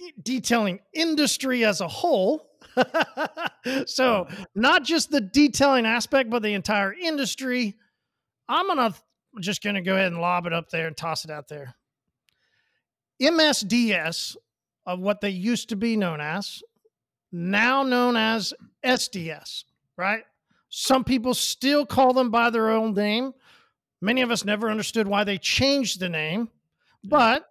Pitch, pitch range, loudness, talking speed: 225 Hz, 190-260 Hz, -23 LUFS, 145 wpm